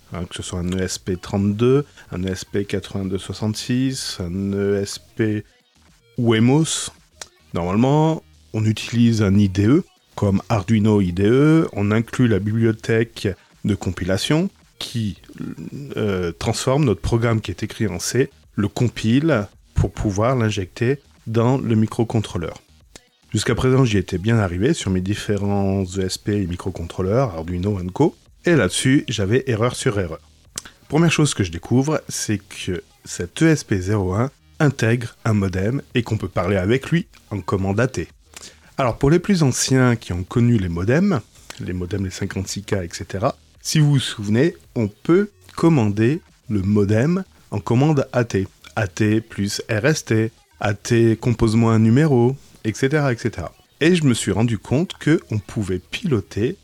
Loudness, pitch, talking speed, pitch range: -20 LUFS, 110 Hz, 135 wpm, 100-125 Hz